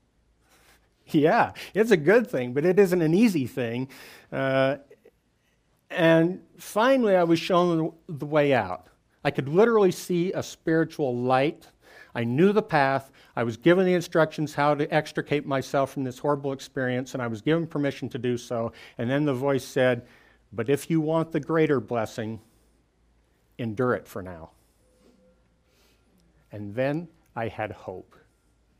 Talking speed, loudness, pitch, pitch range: 150 wpm, -25 LUFS, 140 Hz, 120-165 Hz